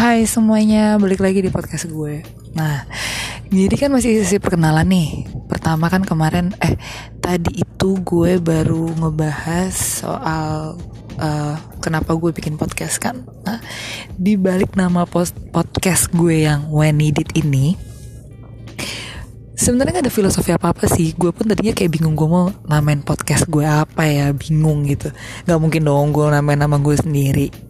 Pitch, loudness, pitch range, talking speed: 160 Hz, -17 LUFS, 145-180 Hz, 145 wpm